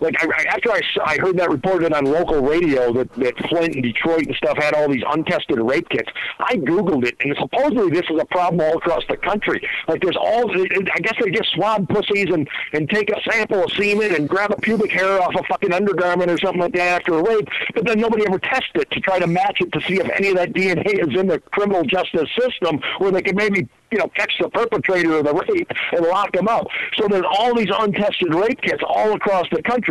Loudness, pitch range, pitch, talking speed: -18 LUFS, 165-210 Hz, 185 Hz, 240 wpm